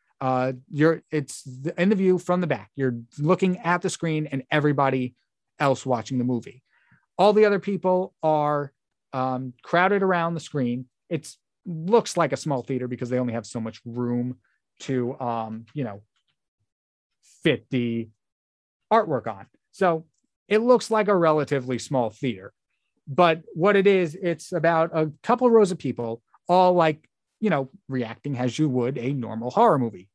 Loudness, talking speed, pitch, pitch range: -24 LUFS, 165 wpm, 140 Hz, 125-175 Hz